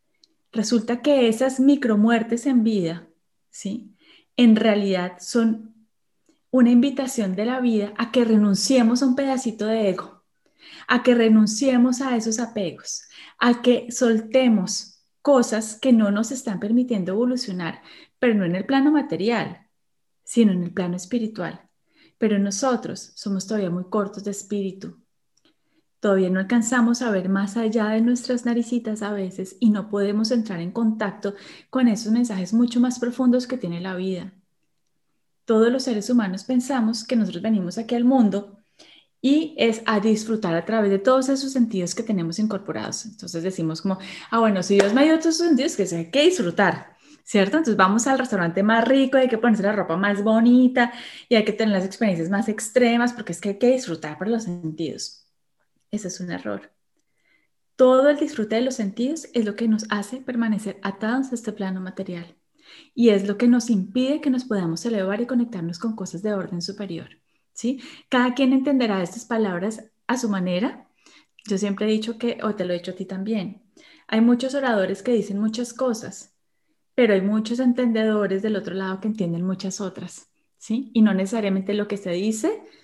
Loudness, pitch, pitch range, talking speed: -22 LUFS, 220 Hz, 195-245 Hz, 175 wpm